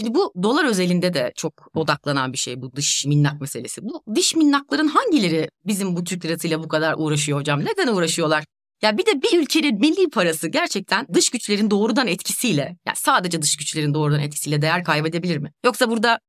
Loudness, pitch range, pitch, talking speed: -20 LUFS, 150-235 Hz, 175 Hz, 190 wpm